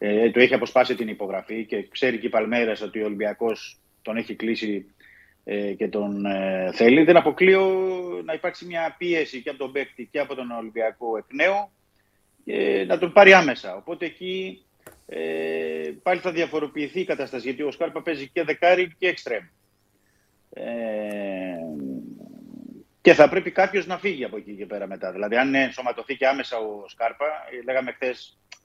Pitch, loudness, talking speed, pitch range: 130 Hz, -23 LUFS, 165 wpm, 110-175 Hz